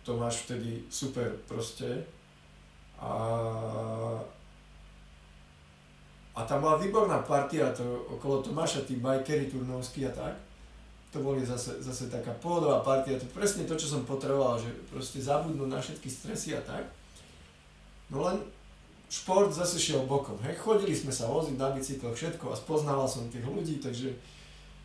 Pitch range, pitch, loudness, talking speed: 110-140 Hz, 130 Hz, -32 LUFS, 140 wpm